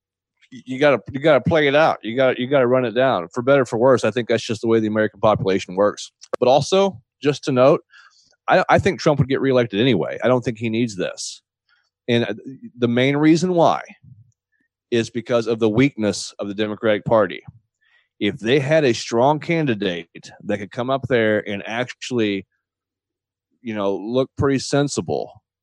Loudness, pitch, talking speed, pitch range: -19 LUFS, 120 Hz, 185 wpm, 110-135 Hz